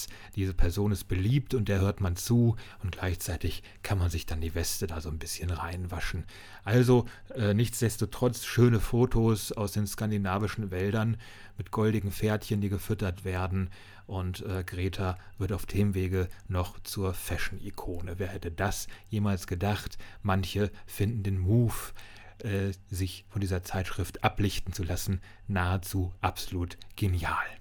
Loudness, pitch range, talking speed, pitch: -31 LUFS, 95-105 Hz, 145 wpm, 100 Hz